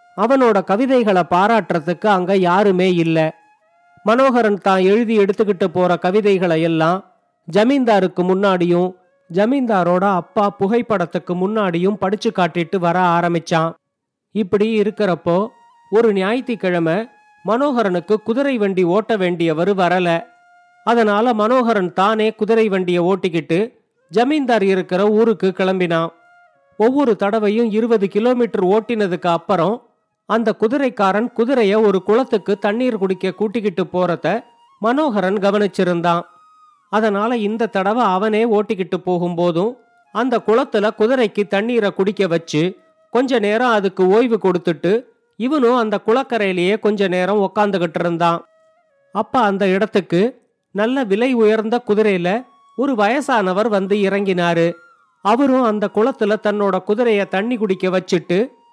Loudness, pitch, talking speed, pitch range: -17 LUFS, 205 Hz, 90 wpm, 185-230 Hz